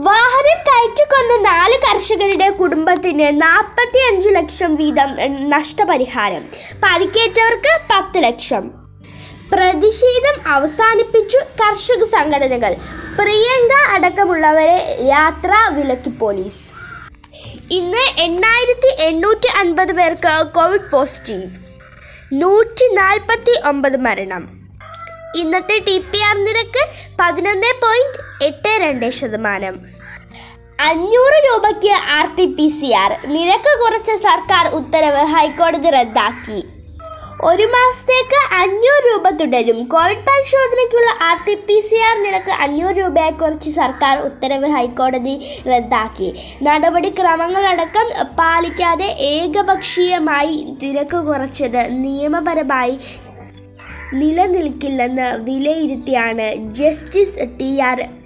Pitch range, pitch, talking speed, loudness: 280-410 Hz, 335 Hz, 85 wpm, -13 LUFS